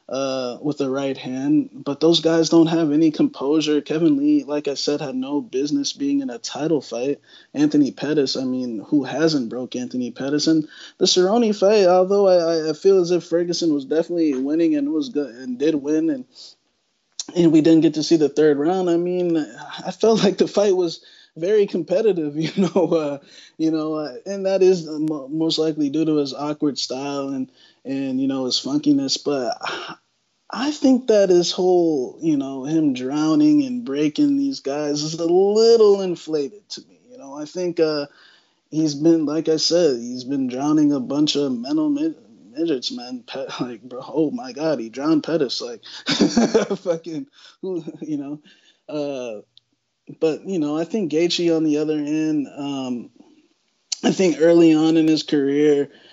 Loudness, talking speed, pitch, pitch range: -20 LUFS, 180 wpm, 165 Hz, 150-235 Hz